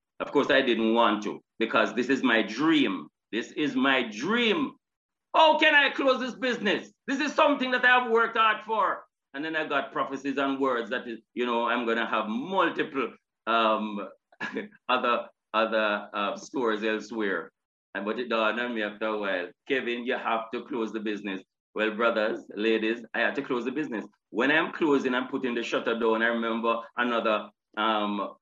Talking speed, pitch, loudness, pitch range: 190 wpm, 115 Hz, -27 LUFS, 110-145 Hz